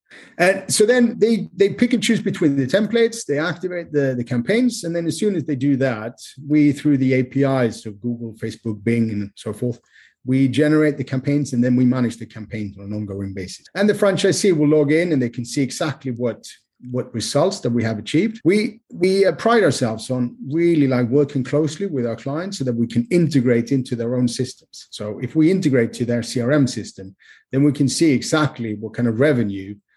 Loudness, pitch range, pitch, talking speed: -19 LUFS, 120-165 Hz, 135 Hz, 210 wpm